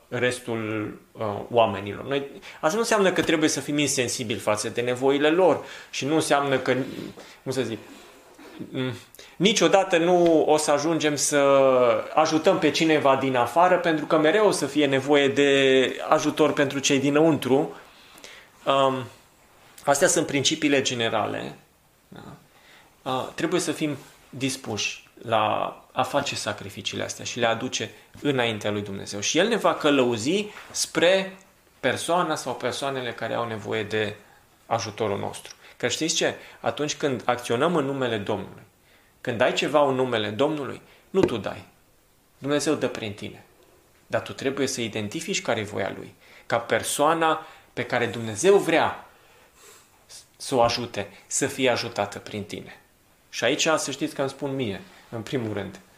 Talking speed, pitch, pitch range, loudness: 150 wpm, 135 Hz, 115-150 Hz, -24 LUFS